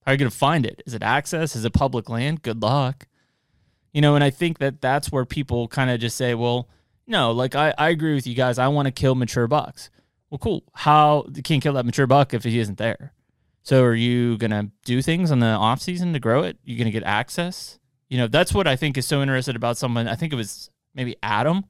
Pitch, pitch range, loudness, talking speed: 130 Hz, 120-145 Hz, -21 LUFS, 255 wpm